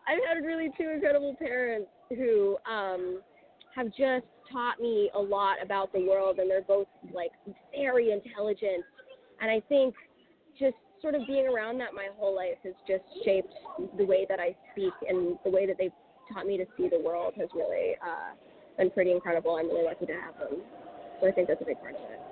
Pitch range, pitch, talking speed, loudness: 190-270 Hz, 205 Hz, 200 wpm, -30 LUFS